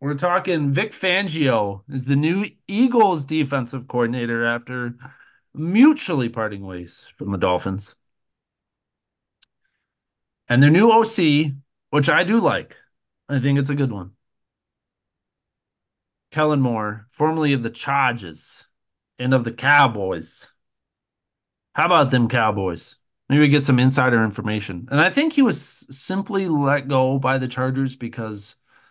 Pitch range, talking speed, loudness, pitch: 115-150 Hz, 130 wpm, -20 LUFS, 135 Hz